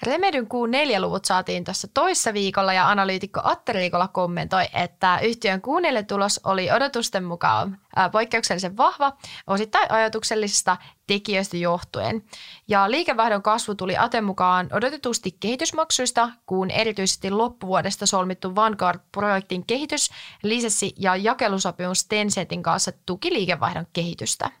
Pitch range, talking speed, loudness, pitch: 185-230 Hz, 115 wpm, -22 LUFS, 200 Hz